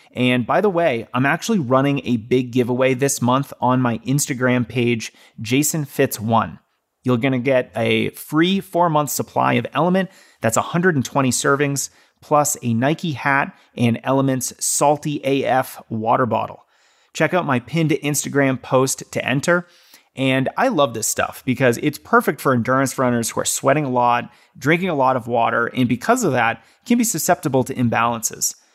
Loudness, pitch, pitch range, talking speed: -19 LUFS, 135 Hz, 125-150 Hz, 165 wpm